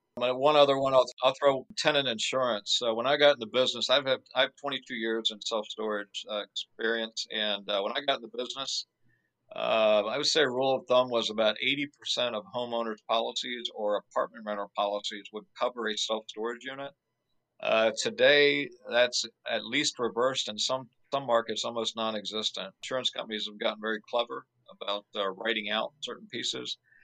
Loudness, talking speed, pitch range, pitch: -29 LUFS, 180 wpm, 110-130 Hz, 115 Hz